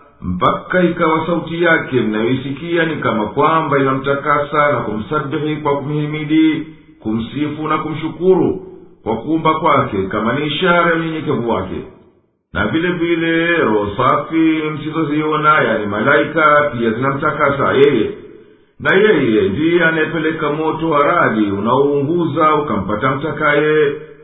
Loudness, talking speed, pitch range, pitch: -15 LUFS, 110 wpm, 140-160 Hz, 155 Hz